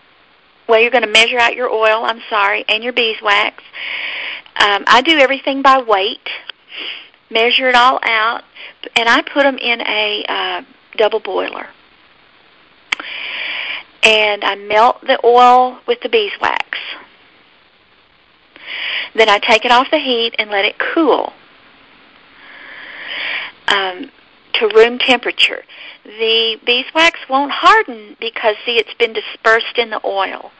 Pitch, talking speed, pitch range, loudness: 245 Hz, 130 wpm, 220-325 Hz, -13 LUFS